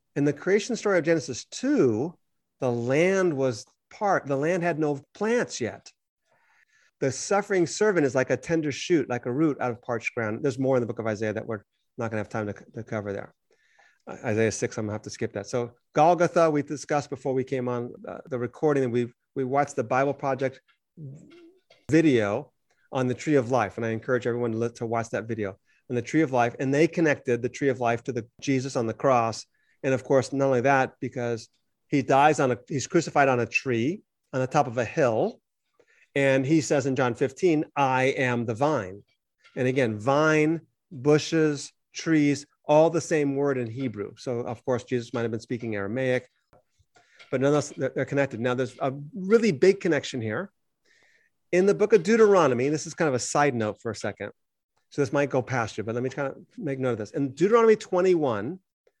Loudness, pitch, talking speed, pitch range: -25 LUFS, 135 Hz, 210 wpm, 120-155 Hz